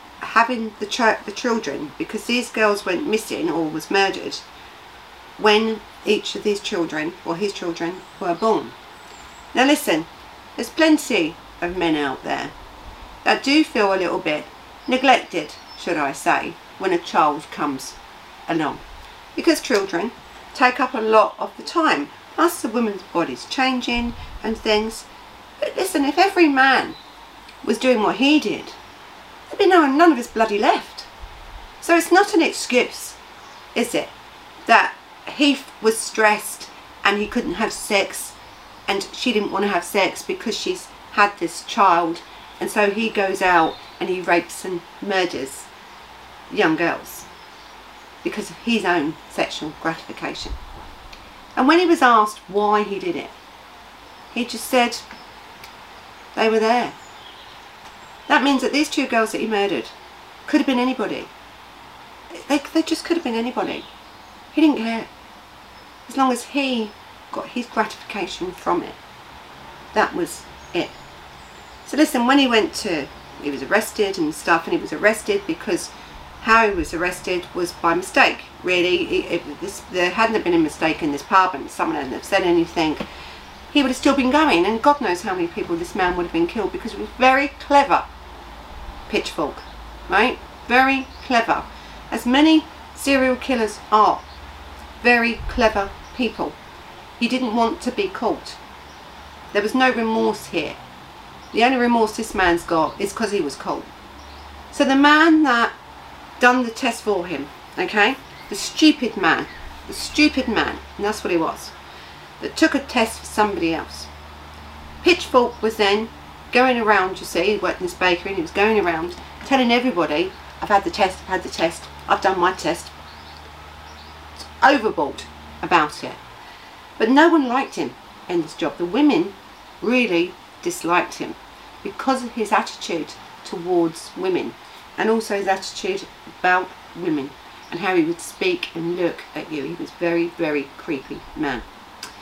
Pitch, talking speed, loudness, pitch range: 225 Hz, 160 wpm, -20 LUFS, 185-270 Hz